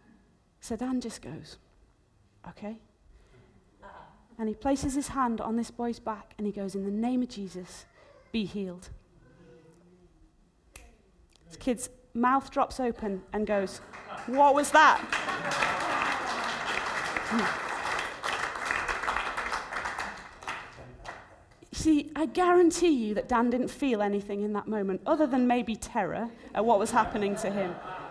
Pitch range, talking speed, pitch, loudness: 200-255 Hz, 120 wpm, 225 Hz, -29 LUFS